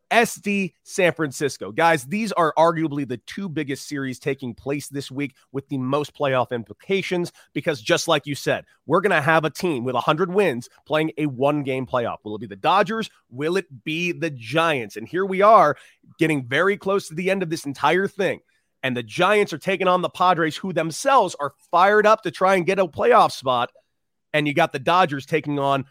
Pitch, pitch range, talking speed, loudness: 160 Hz, 140-185 Hz, 205 wpm, -21 LUFS